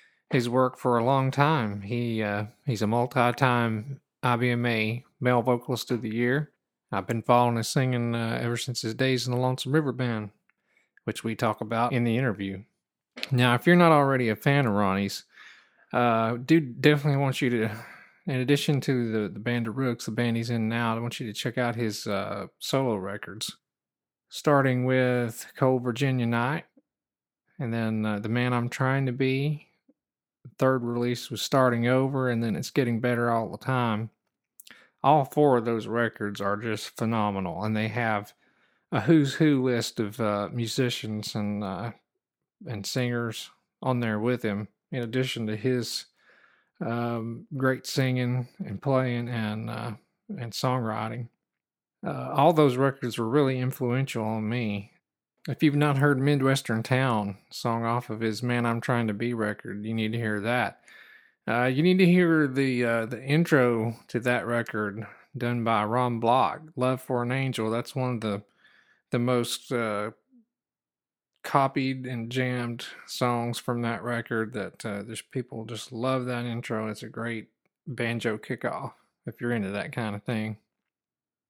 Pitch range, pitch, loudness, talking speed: 110-130 Hz, 120 Hz, -27 LUFS, 170 wpm